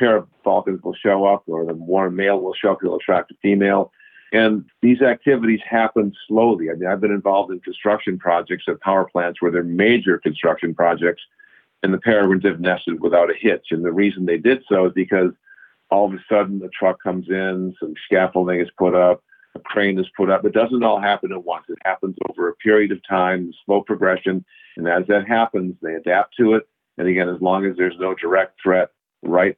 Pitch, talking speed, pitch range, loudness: 95 Hz, 215 wpm, 90-100 Hz, -19 LUFS